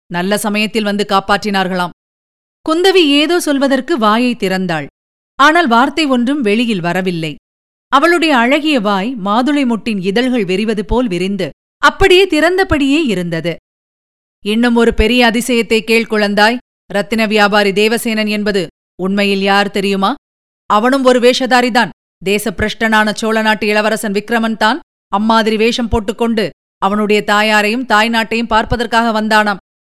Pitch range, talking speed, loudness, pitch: 205-245 Hz, 110 wpm, -13 LUFS, 220 Hz